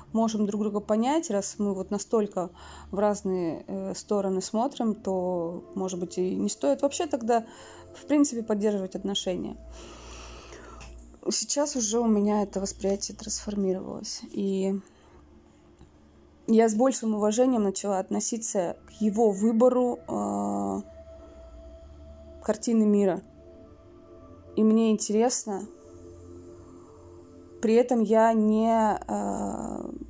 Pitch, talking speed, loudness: 200 Hz, 105 wpm, -27 LUFS